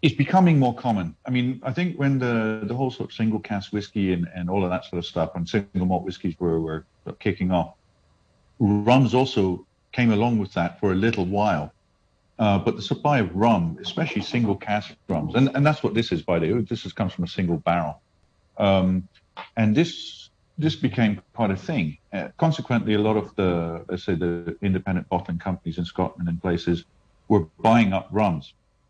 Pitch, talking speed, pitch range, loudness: 105 Hz, 200 wpm, 90-120 Hz, -24 LUFS